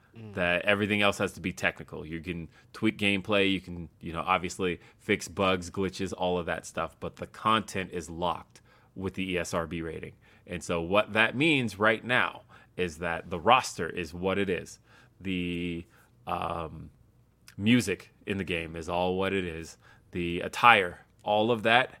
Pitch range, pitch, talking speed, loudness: 90-105 Hz, 95 Hz, 170 wpm, -28 LUFS